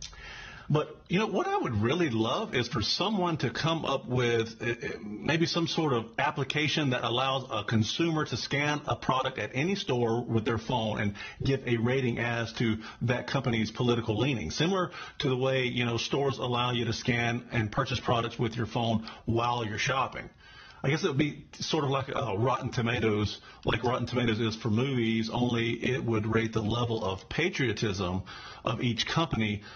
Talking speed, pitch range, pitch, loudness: 190 wpm, 115-135 Hz, 120 Hz, -29 LUFS